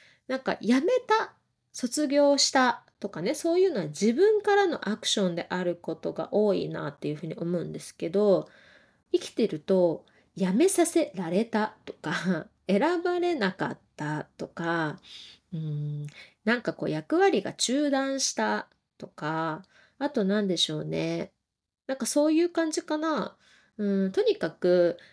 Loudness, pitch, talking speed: -27 LUFS, 210 Hz, 275 characters per minute